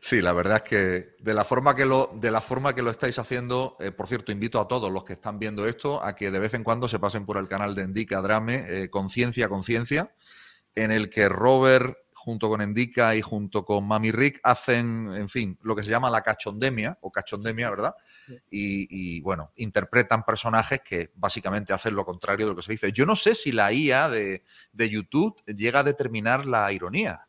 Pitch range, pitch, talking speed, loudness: 100-125 Hz, 110 Hz, 210 wpm, -25 LUFS